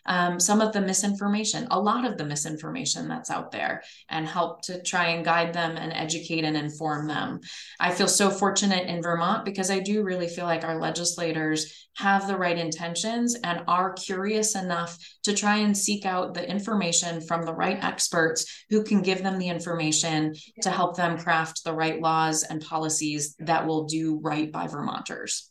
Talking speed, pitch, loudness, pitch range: 185 wpm, 170 Hz, -26 LUFS, 160-195 Hz